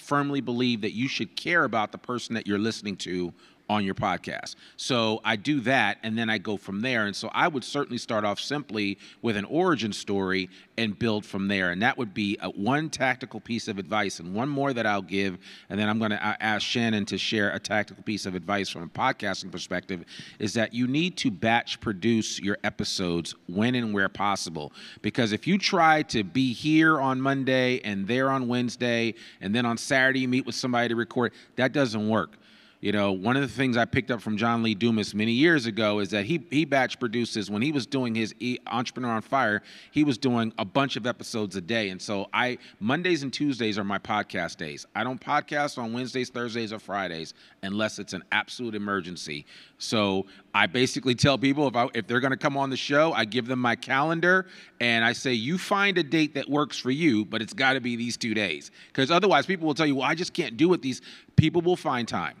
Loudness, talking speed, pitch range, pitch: -26 LUFS, 225 wpm, 105-135 Hz, 115 Hz